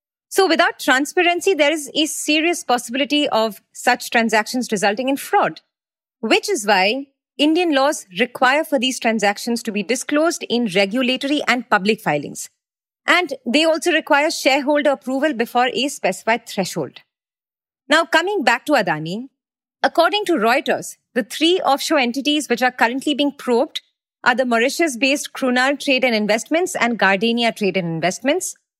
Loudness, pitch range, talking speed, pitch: -18 LUFS, 235-305 Hz, 150 wpm, 265 Hz